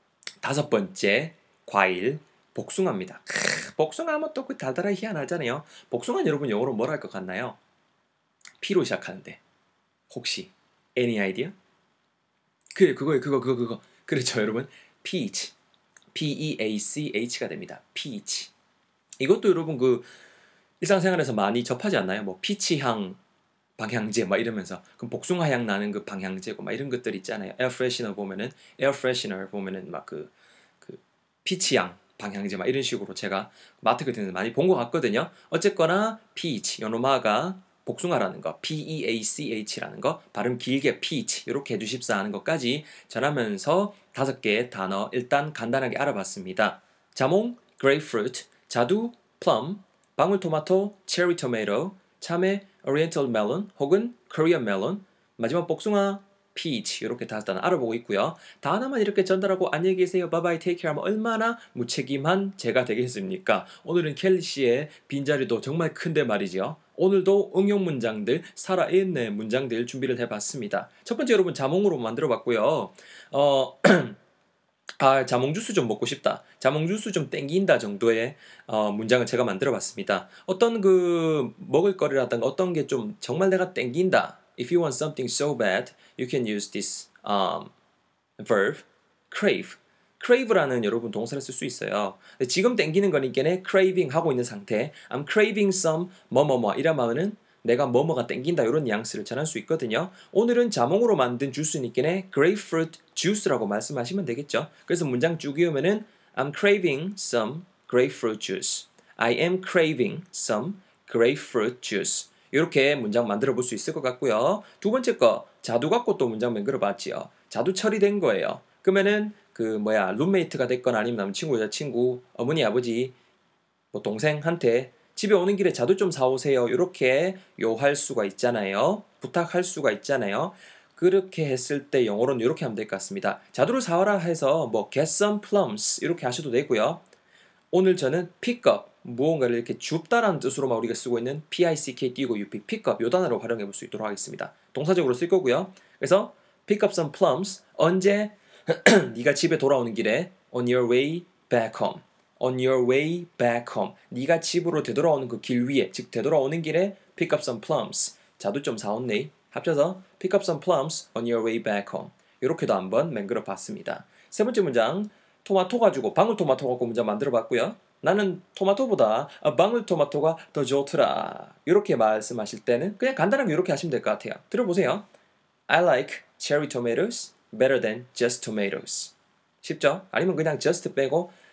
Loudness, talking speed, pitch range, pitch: -25 LUFS, 400 characters per minute, 125-190 Hz, 155 Hz